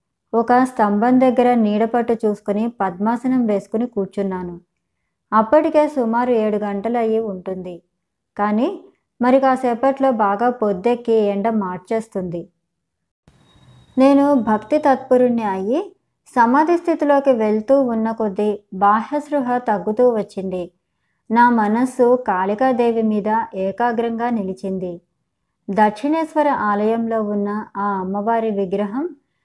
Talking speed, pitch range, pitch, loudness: 95 wpm, 205-250 Hz, 225 Hz, -18 LUFS